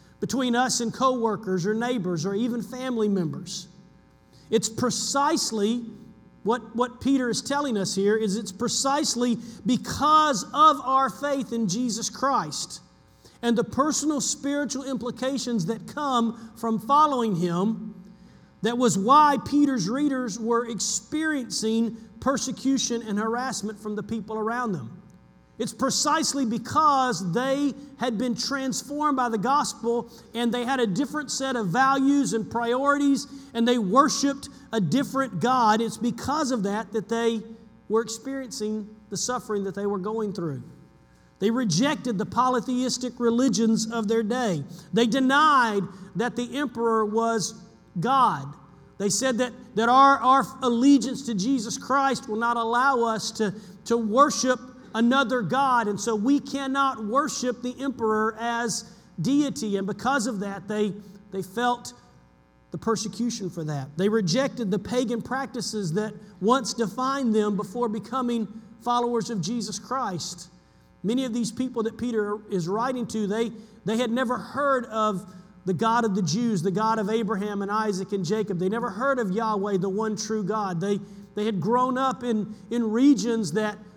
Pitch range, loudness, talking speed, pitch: 210-255 Hz, -25 LUFS, 150 wpm, 230 Hz